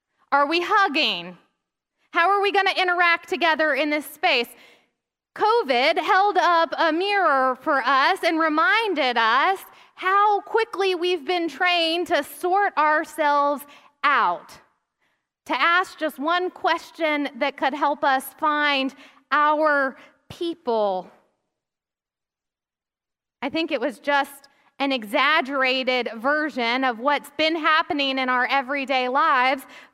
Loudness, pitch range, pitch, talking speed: -21 LUFS, 275-345 Hz, 305 Hz, 120 wpm